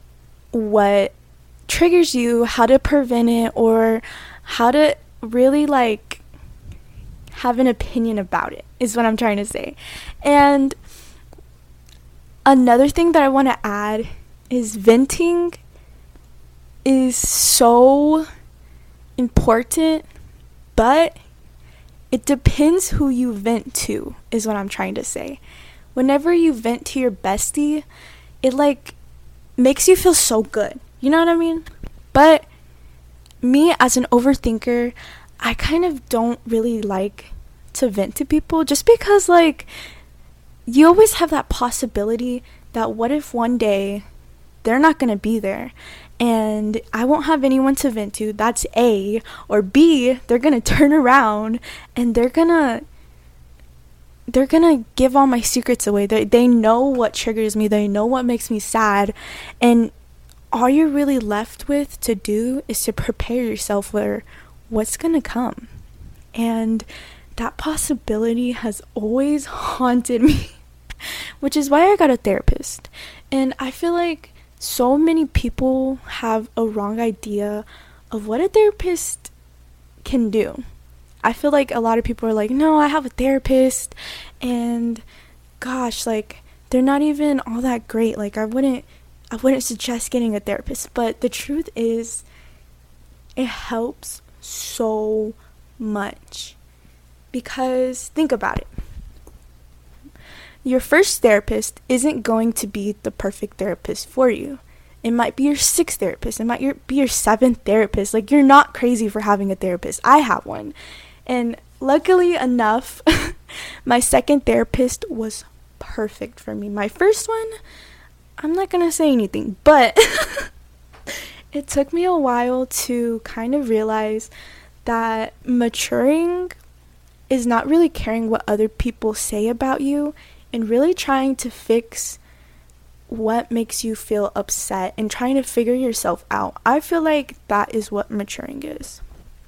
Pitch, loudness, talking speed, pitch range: 235 Hz, -18 LUFS, 140 wpm, 210-275 Hz